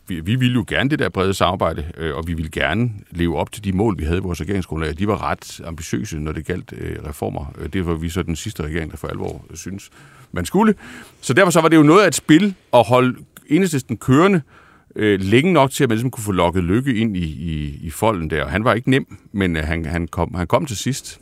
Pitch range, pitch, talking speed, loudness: 85-125 Hz, 95 Hz, 245 wpm, -19 LUFS